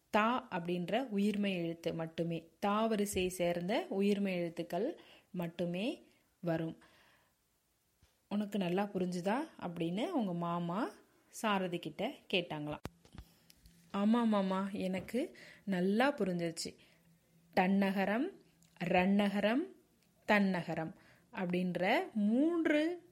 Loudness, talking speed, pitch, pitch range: -35 LUFS, 80 wpm, 195 Hz, 175-215 Hz